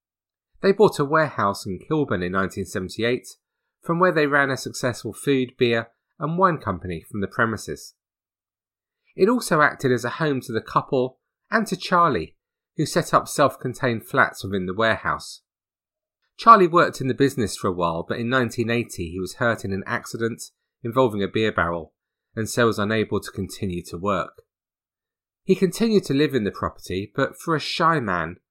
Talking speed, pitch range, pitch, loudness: 175 wpm, 95-145 Hz, 115 Hz, -22 LUFS